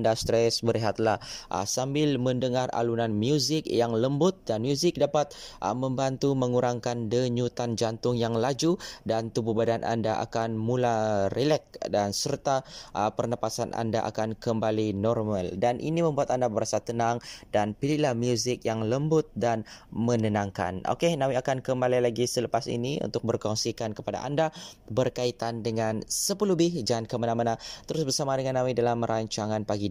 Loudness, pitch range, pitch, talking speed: -28 LUFS, 110-130 Hz, 120 Hz, 140 wpm